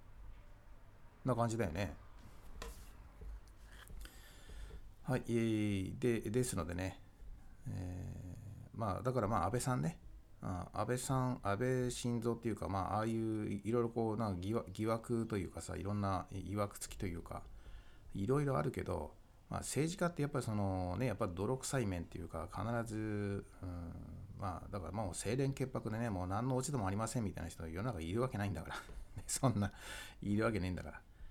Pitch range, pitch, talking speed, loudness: 95-115 Hz, 100 Hz, 315 characters per minute, -40 LUFS